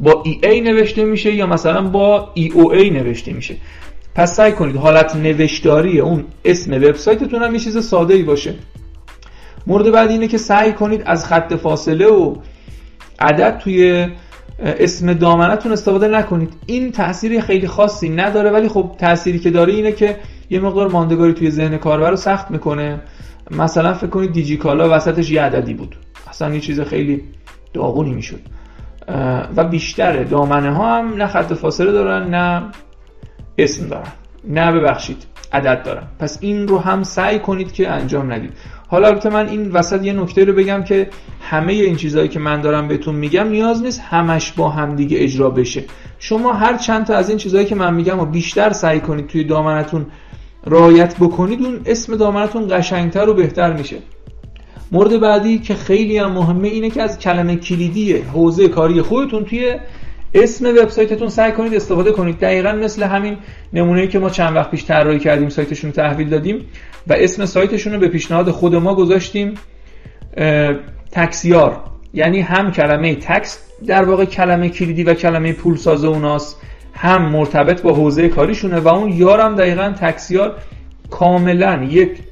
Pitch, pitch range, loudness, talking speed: 175 Hz, 155-205 Hz, -14 LUFS, 165 wpm